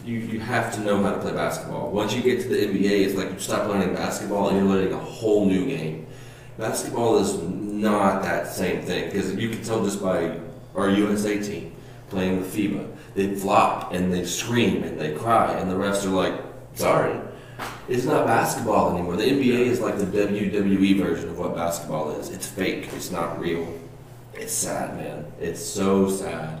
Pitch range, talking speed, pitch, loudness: 95-105 Hz, 195 wpm, 95 Hz, -24 LUFS